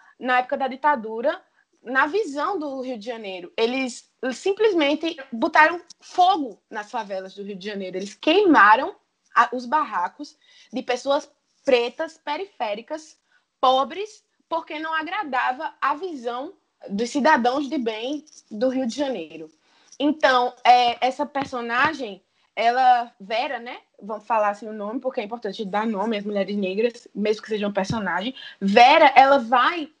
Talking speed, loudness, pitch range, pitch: 140 wpm, -22 LUFS, 225-305 Hz, 260 Hz